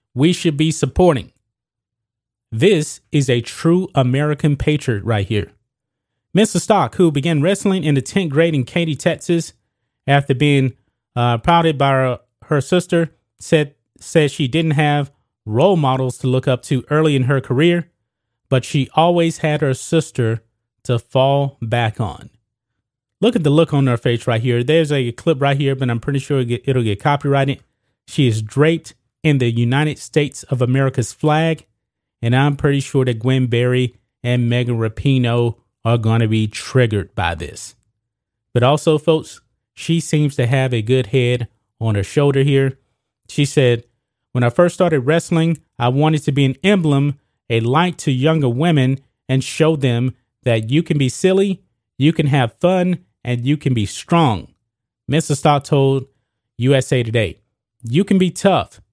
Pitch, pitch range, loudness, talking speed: 135 Hz, 120-155 Hz, -17 LUFS, 165 wpm